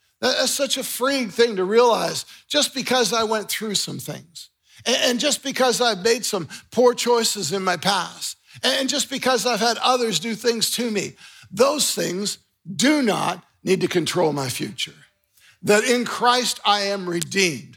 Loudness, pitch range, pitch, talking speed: -21 LUFS, 195-245 Hz, 230 Hz, 170 wpm